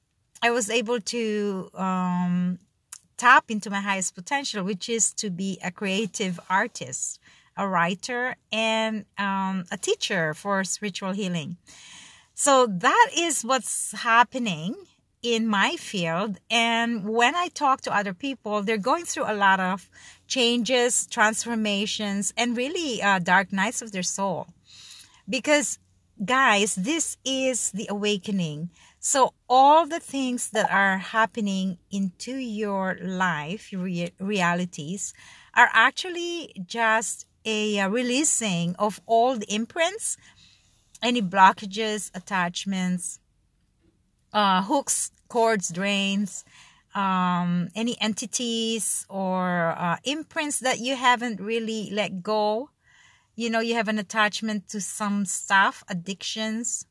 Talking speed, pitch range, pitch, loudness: 120 wpm, 190-240 Hz, 210 Hz, -24 LUFS